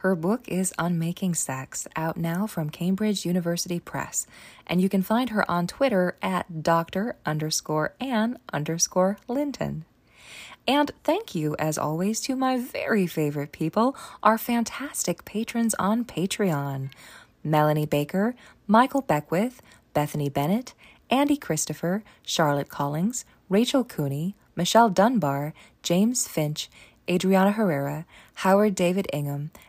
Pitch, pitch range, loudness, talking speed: 185 Hz, 155-220 Hz, -25 LUFS, 125 wpm